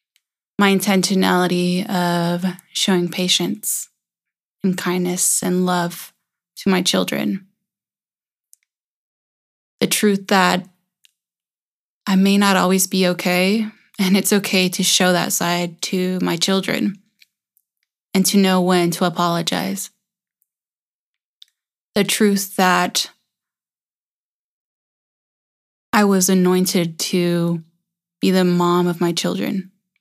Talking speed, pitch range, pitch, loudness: 100 wpm, 180-195 Hz, 185 Hz, -18 LUFS